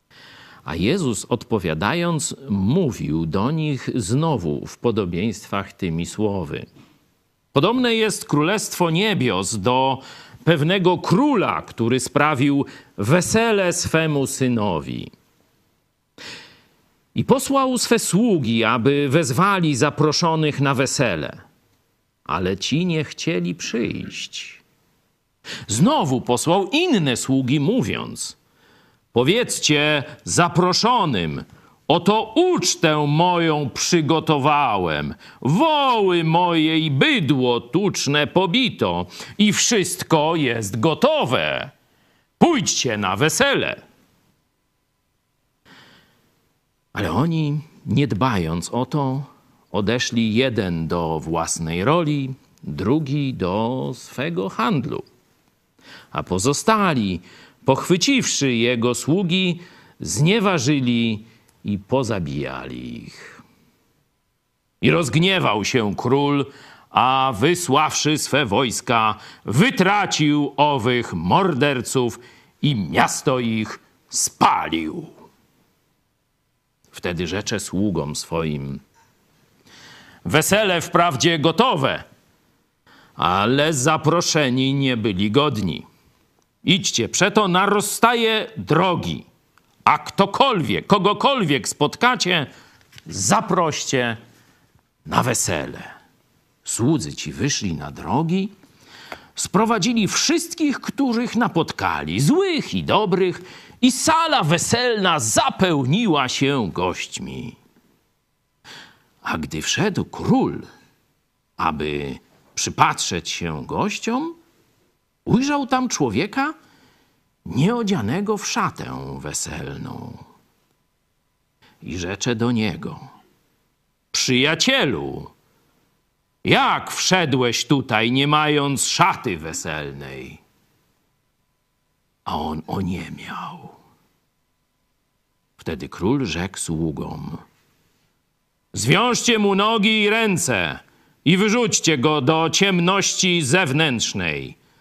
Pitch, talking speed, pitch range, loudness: 150 Hz, 80 wpm, 120-185 Hz, -20 LUFS